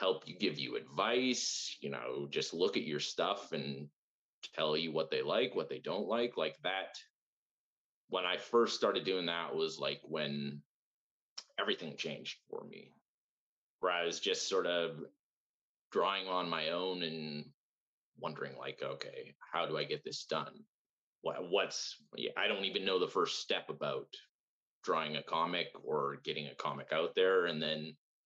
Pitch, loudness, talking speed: 100 Hz, -37 LUFS, 165 wpm